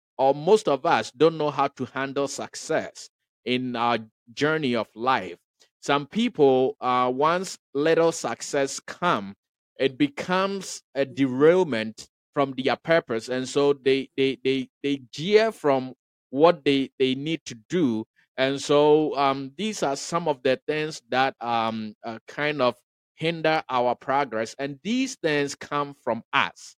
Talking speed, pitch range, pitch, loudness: 150 wpm, 130-155 Hz, 140 Hz, -24 LUFS